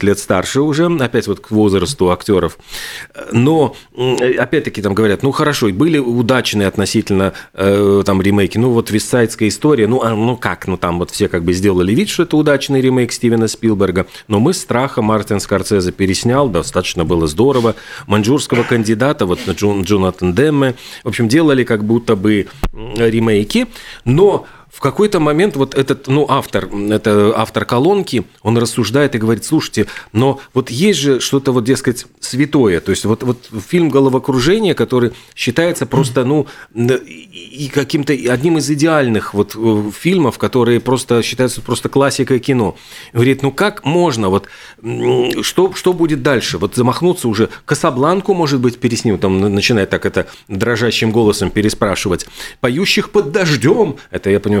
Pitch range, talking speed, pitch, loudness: 105-140 Hz, 155 wpm, 120 Hz, -14 LUFS